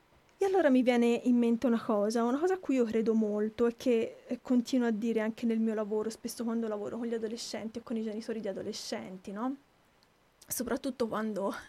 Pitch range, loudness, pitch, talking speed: 220-245 Hz, -31 LUFS, 235 Hz, 200 wpm